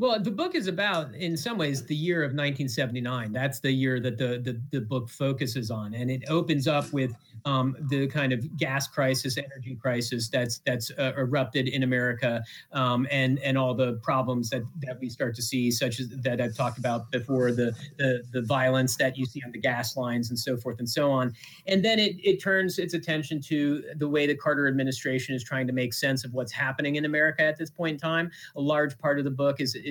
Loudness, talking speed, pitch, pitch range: -28 LUFS, 225 wpm, 135 Hz, 125-150 Hz